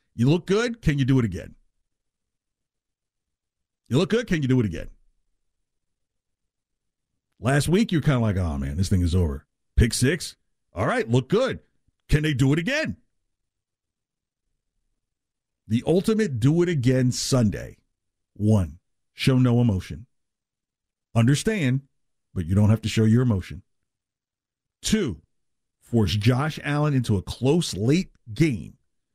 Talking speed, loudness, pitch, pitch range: 140 wpm, -23 LUFS, 125 Hz, 105-145 Hz